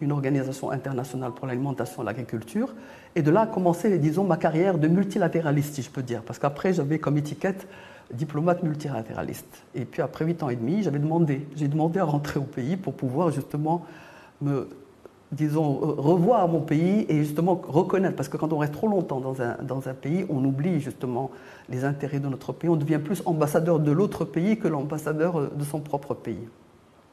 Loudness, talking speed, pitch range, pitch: -26 LUFS, 195 wpm, 135-170 Hz, 150 Hz